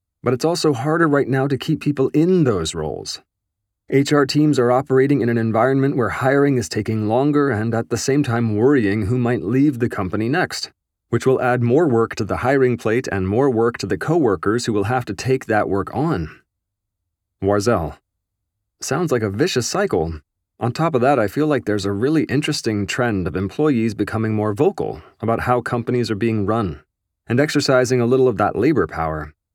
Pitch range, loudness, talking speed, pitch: 100-130 Hz, -19 LUFS, 195 wpm, 115 Hz